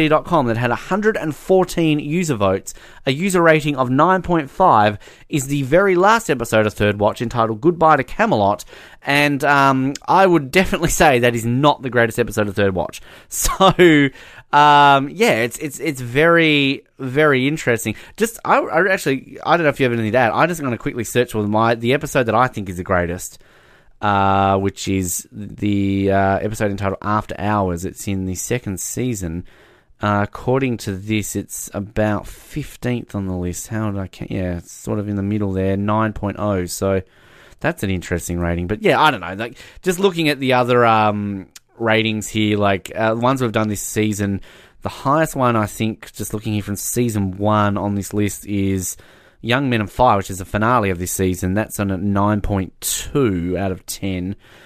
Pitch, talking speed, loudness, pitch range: 110 Hz, 190 wpm, -18 LUFS, 100-135 Hz